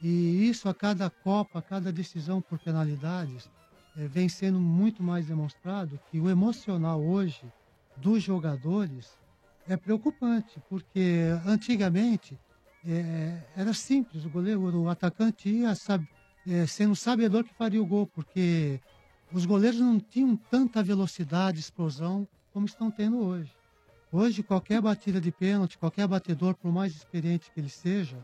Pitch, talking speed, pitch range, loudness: 185 Hz, 145 wpm, 165-205 Hz, -29 LUFS